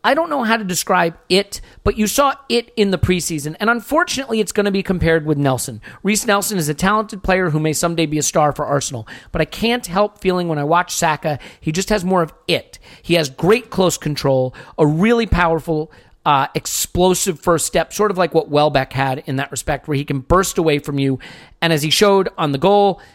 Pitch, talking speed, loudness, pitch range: 170 Hz, 225 wpm, -17 LUFS, 150-200 Hz